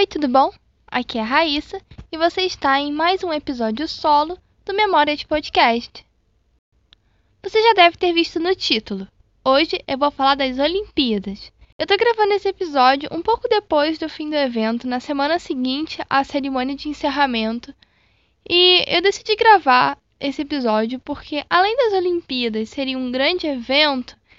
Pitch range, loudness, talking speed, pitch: 270-355 Hz, -18 LUFS, 160 wpm, 295 Hz